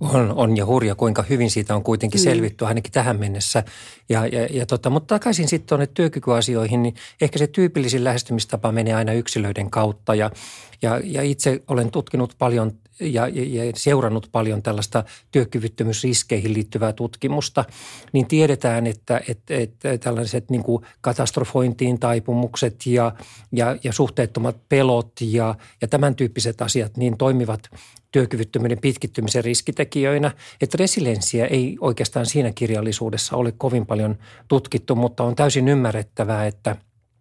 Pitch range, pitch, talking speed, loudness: 115-130 Hz, 120 Hz, 135 wpm, -21 LUFS